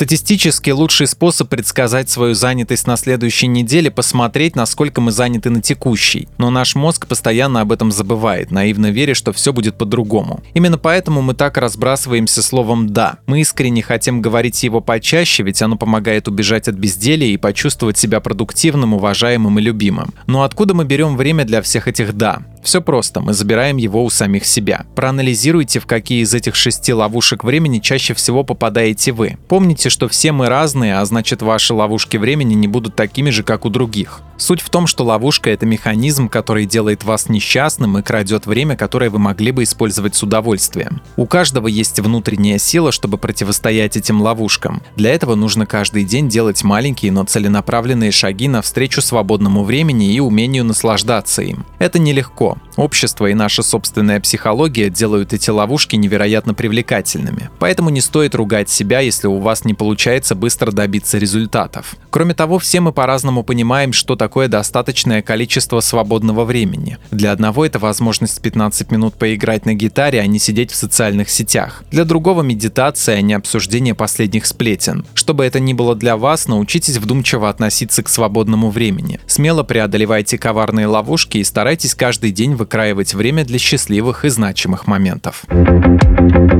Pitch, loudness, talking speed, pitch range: 115 Hz, -13 LUFS, 160 wpm, 110-130 Hz